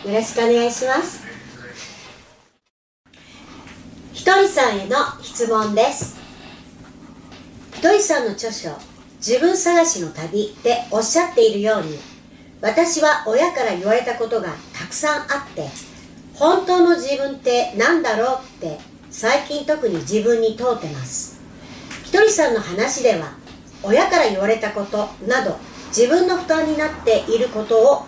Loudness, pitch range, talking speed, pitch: -18 LUFS, 220-310 Hz, 270 characters per minute, 250 Hz